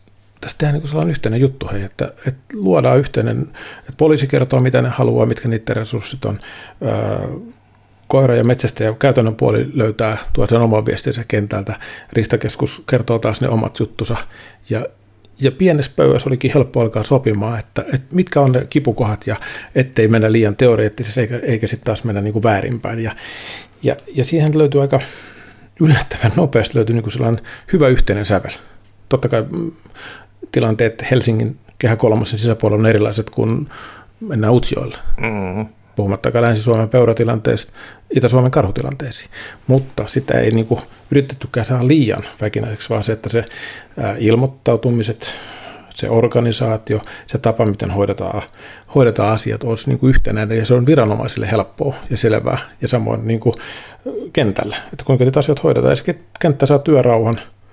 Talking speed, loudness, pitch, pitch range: 145 wpm, -16 LUFS, 115 Hz, 110-130 Hz